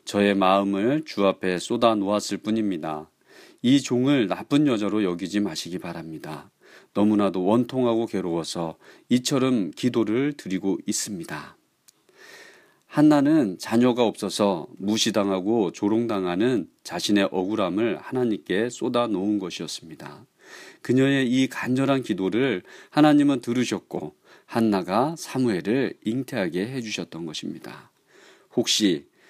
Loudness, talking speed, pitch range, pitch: -24 LUFS, 285 characters per minute, 95-130 Hz, 110 Hz